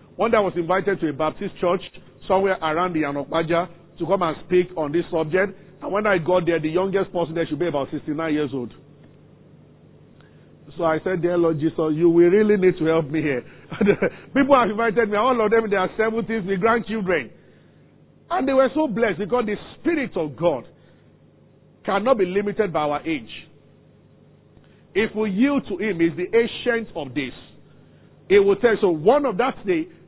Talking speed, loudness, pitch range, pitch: 190 wpm, -21 LUFS, 165-220 Hz, 185 Hz